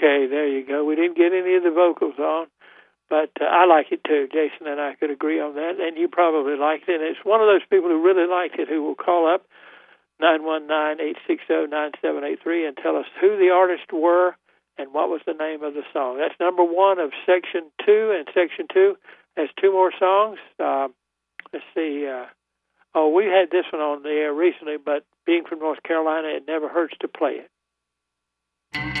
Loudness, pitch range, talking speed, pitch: -21 LUFS, 150-180 Hz, 220 wpm, 160 Hz